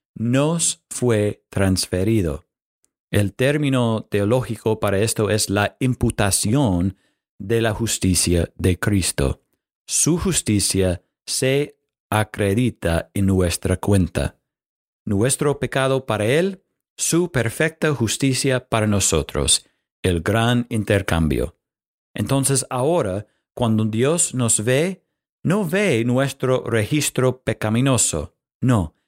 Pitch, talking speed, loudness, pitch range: 115 Hz, 95 wpm, -20 LUFS, 100-135 Hz